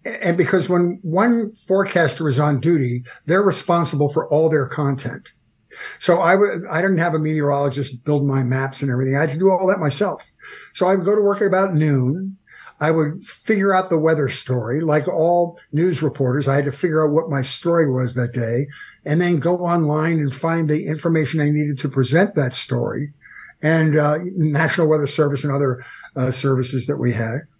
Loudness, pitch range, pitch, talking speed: -19 LUFS, 140-175 Hz, 155 Hz, 200 wpm